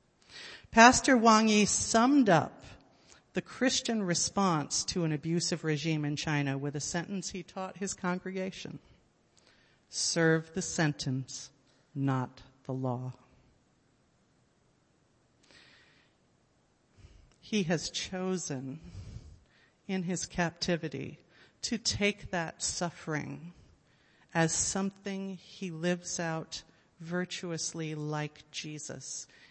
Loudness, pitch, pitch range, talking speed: -30 LUFS, 165 Hz, 150-190 Hz, 90 wpm